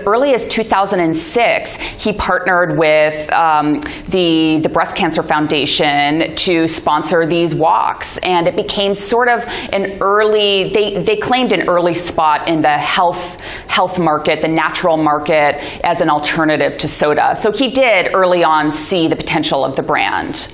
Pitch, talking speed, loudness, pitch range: 170 Hz, 155 wpm, -14 LUFS, 155-195 Hz